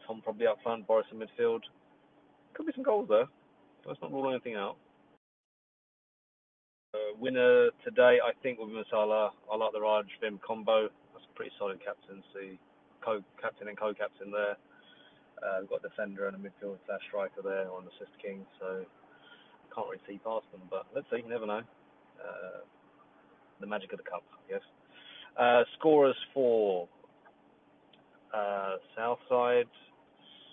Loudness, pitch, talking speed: -32 LUFS, 110 Hz, 160 wpm